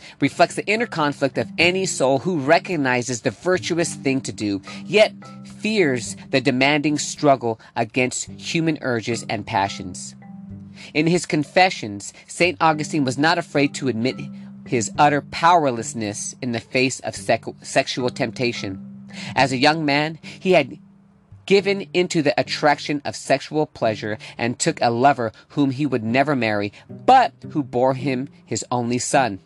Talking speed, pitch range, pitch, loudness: 150 wpm, 115-160 Hz, 135 Hz, -21 LUFS